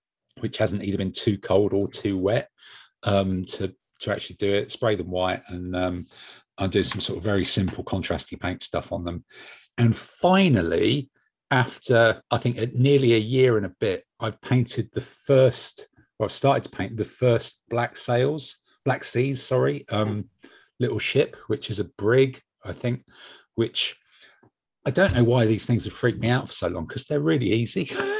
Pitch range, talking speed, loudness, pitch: 100-130 Hz, 185 wpm, -24 LUFS, 115 Hz